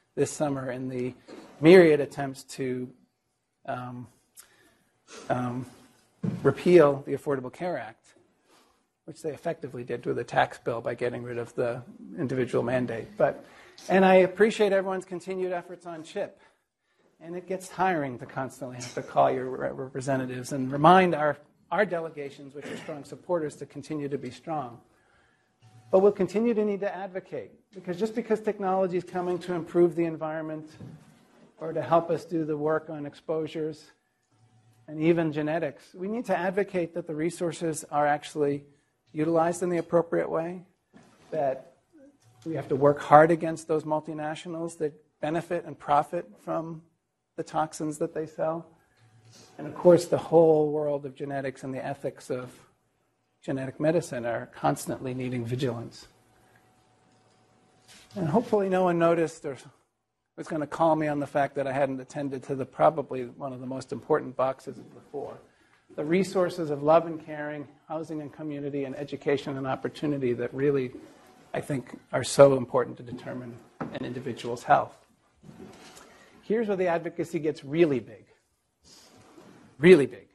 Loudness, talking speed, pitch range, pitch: -27 LUFS, 155 wpm, 130-170 Hz, 150 Hz